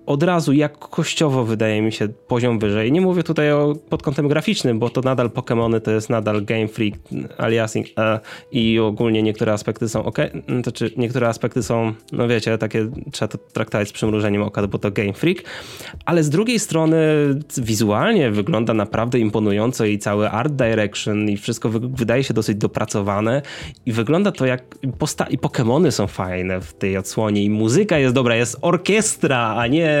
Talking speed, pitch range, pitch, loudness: 175 wpm, 110-145 Hz, 115 Hz, -19 LUFS